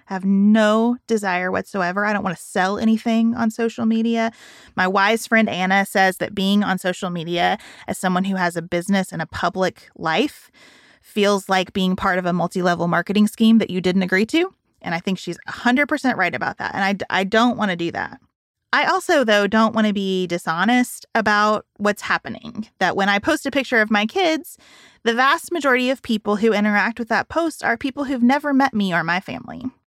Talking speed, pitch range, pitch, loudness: 205 wpm, 185-230 Hz, 210 Hz, -19 LUFS